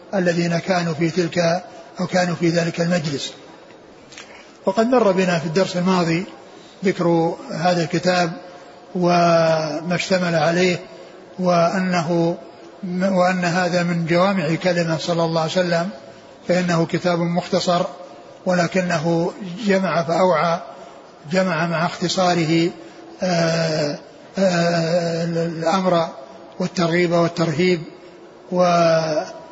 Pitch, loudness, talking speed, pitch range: 175 Hz, -20 LUFS, 95 wpm, 170-180 Hz